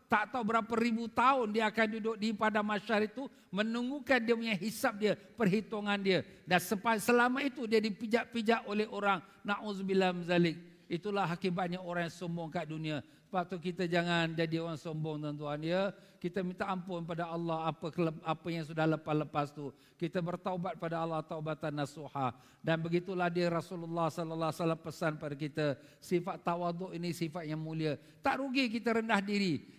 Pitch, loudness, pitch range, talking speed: 180 Hz, -34 LUFS, 160-215 Hz, 165 wpm